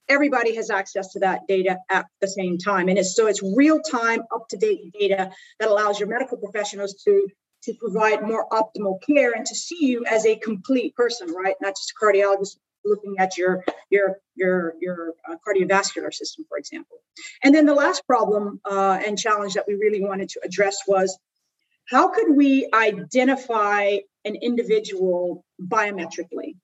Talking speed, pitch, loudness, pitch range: 170 wpm, 205 Hz, -22 LUFS, 195-240 Hz